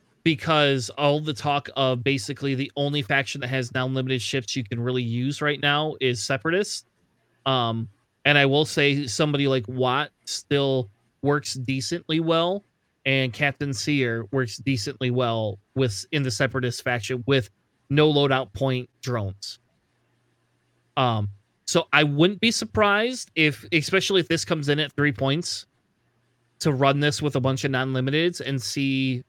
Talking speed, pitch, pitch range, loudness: 150 wpm, 135 Hz, 125-150 Hz, -24 LUFS